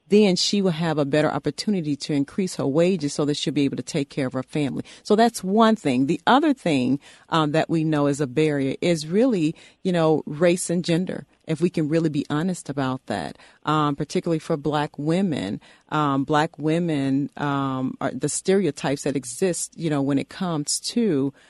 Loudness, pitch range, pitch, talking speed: -23 LUFS, 145-180 Hz, 155 Hz, 200 wpm